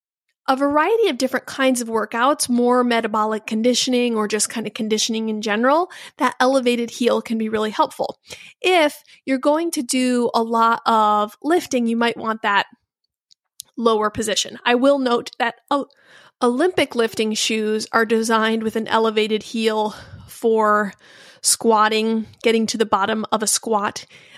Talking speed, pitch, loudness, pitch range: 150 wpm, 230 Hz, -19 LUFS, 220-255 Hz